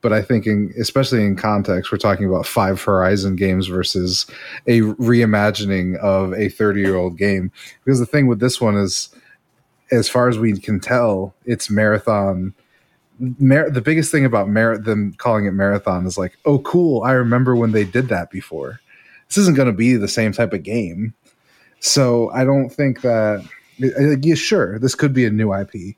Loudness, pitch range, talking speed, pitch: -17 LUFS, 100-125 Hz, 185 wpm, 110 Hz